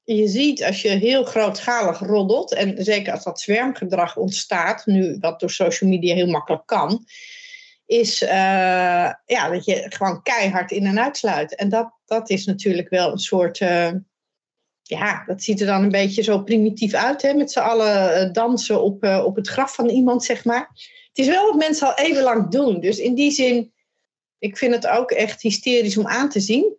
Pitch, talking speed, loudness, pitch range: 215 Hz, 195 wpm, -19 LUFS, 195-245 Hz